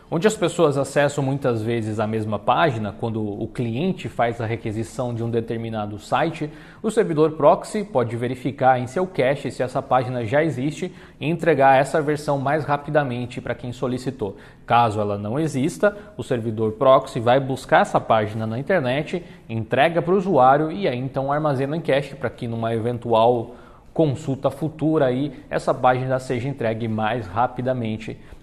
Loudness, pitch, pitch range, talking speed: -22 LUFS, 130 Hz, 115-150 Hz, 165 wpm